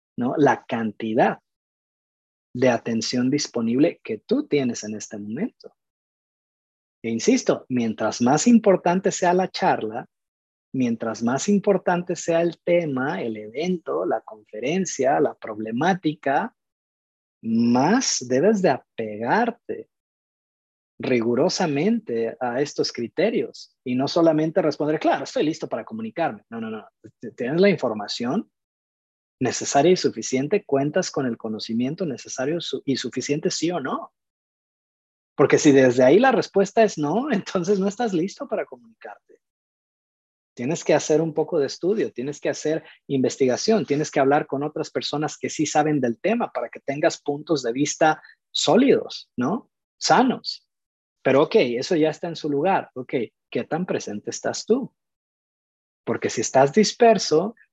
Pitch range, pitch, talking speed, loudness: 115-185 Hz, 145 Hz, 135 wpm, -22 LUFS